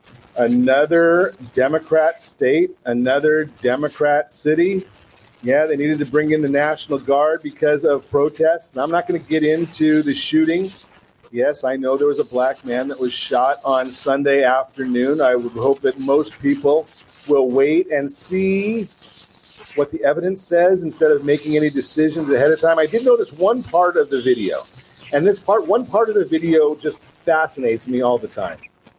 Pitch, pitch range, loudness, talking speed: 150 Hz, 135-175 Hz, -18 LUFS, 175 wpm